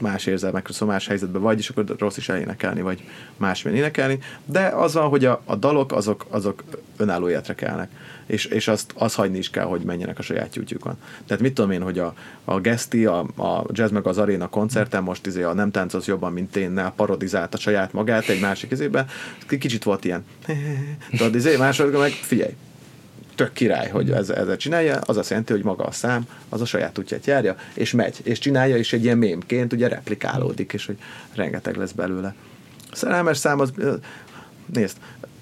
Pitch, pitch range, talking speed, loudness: 110 Hz, 95-130 Hz, 195 wpm, -23 LUFS